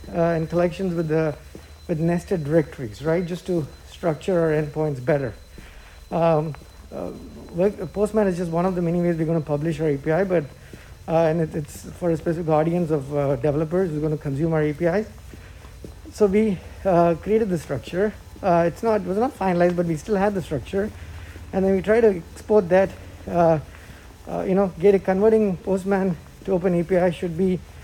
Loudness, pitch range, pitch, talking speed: -22 LUFS, 155-190 Hz, 170 Hz, 190 wpm